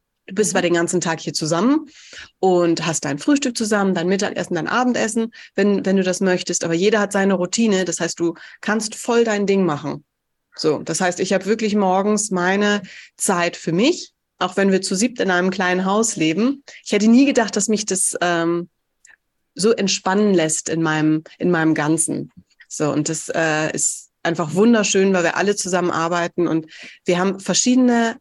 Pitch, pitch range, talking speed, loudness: 190 Hz, 170-210 Hz, 185 wpm, -19 LUFS